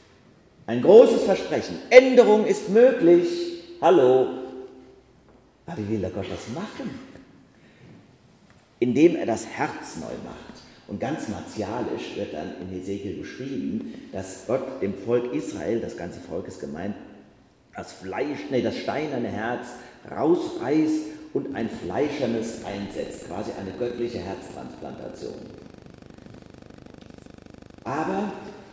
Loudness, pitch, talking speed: -23 LUFS, 125 Hz, 110 wpm